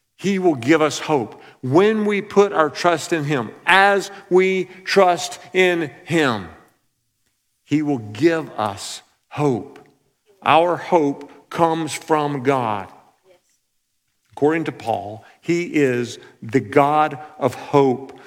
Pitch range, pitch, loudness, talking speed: 135-175 Hz, 150 Hz, -19 LUFS, 120 wpm